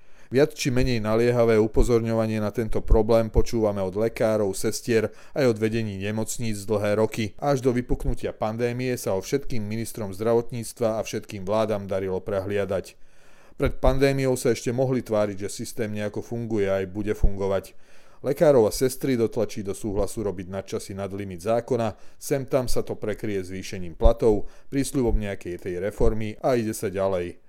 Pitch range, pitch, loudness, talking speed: 100-120 Hz, 110 Hz, -25 LUFS, 155 wpm